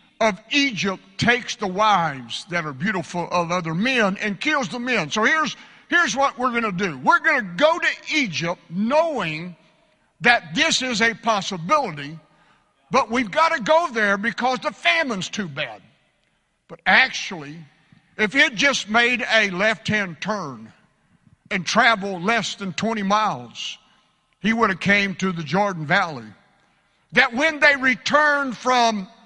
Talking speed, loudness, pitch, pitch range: 160 wpm, -20 LUFS, 215 Hz, 185-255 Hz